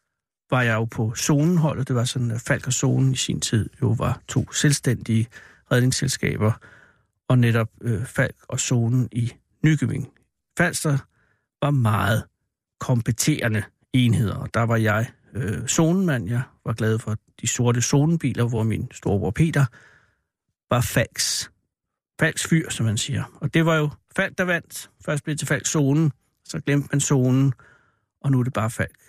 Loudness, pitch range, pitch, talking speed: -23 LUFS, 115-145 Hz, 130 Hz, 165 wpm